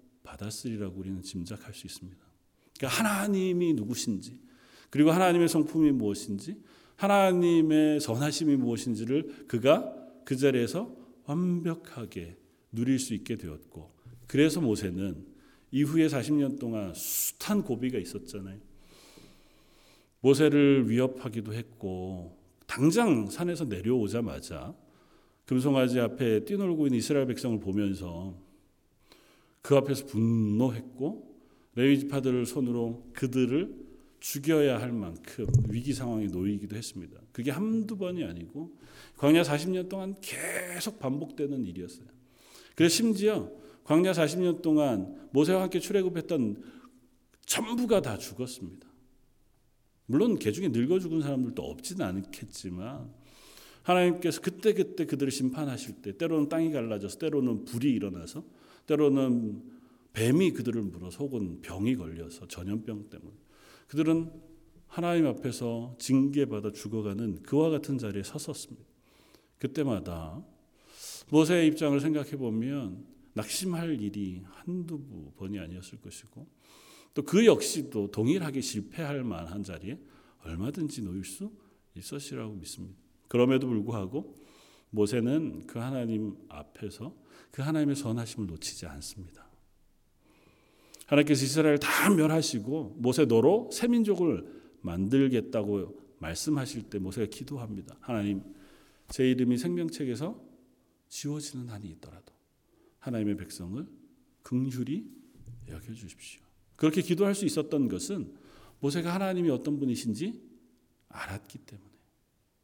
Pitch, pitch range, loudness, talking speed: 130 Hz, 105-155 Hz, -29 LUFS, 295 characters per minute